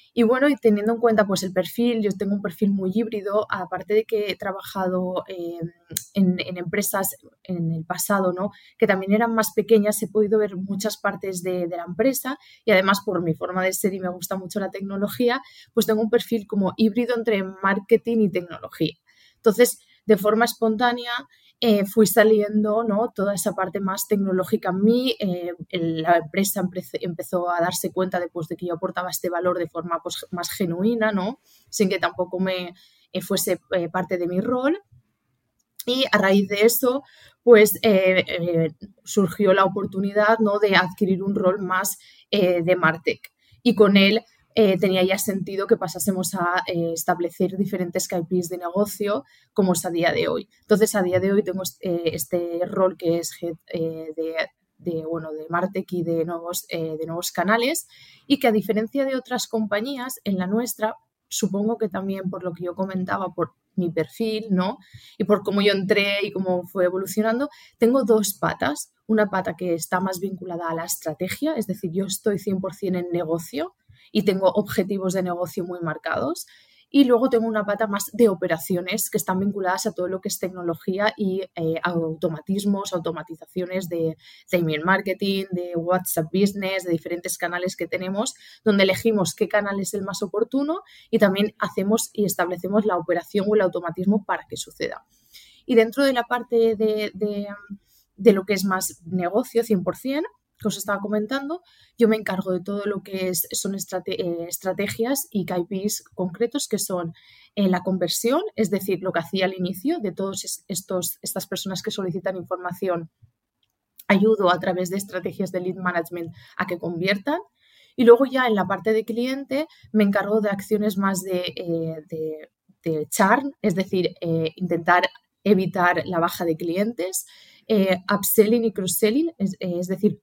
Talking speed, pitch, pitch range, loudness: 180 wpm, 195 Hz, 180-215 Hz, -23 LUFS